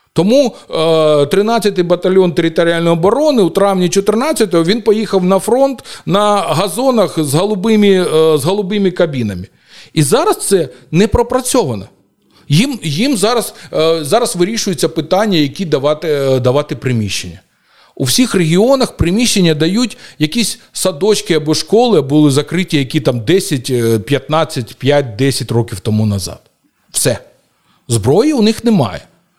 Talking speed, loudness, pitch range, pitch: 120 wpm, -13 LUFS, 145-210 Hz, 170 Hz